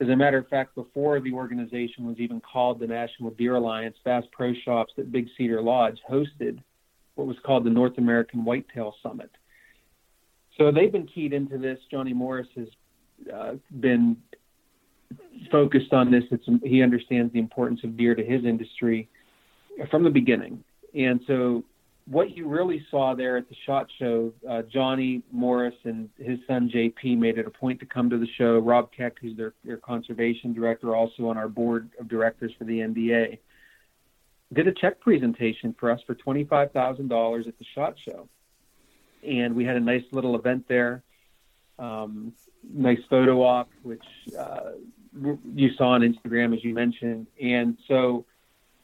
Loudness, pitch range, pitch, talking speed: -25 LUFS, 115-130 Hz, 120 Hz, 165 wpm